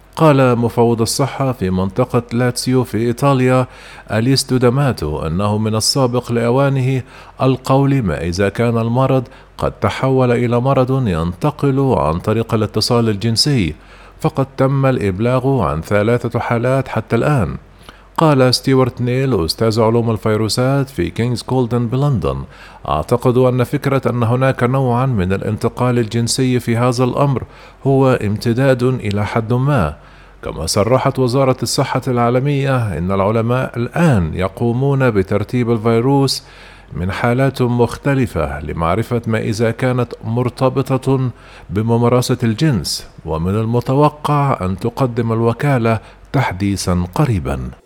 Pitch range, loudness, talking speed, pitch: 110-130 Hz, -16 LUFS, 115 wpm, 120 Hz